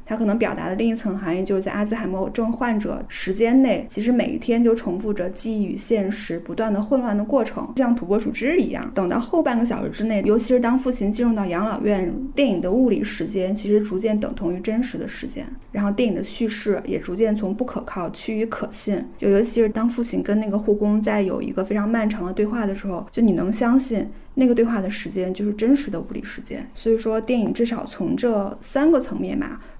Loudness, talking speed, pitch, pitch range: -22 LUFS, 350 characters per minute, 220 Hz, 205-240 Hz